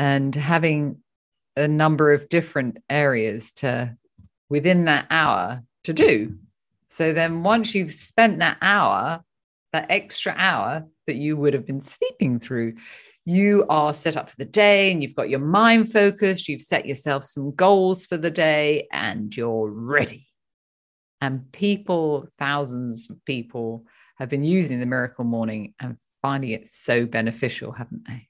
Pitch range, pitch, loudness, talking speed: 120-170 Hz, 145 Hz, -21 LUFS, 155 wpm